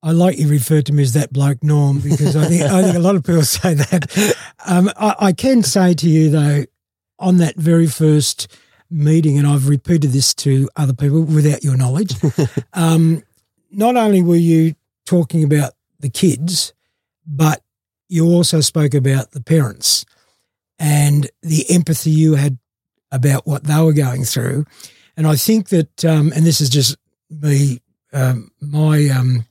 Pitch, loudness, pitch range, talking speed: 150 Hz, -15 LUFS, 140-165 Hz, 170 wpm